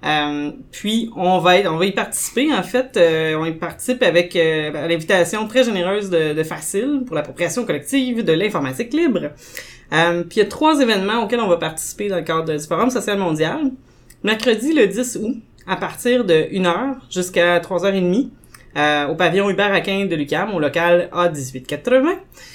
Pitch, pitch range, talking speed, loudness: 185 Hz, 165-235 Hz, 175 wpm, -18 LUFS